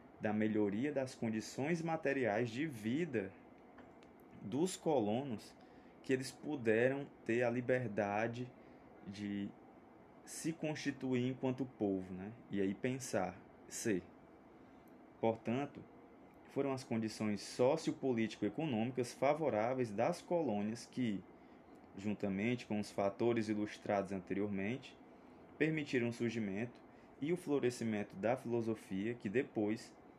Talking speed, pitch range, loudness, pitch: 100 wpm, 105-130 Hz, -39 LUFS, 115 Hz